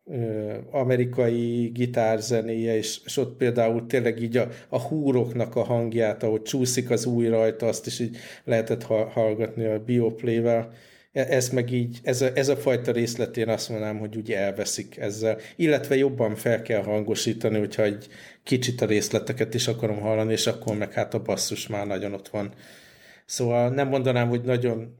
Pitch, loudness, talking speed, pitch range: 115 Hz, -25 LUFS, 170 wpm, 110-125 Hz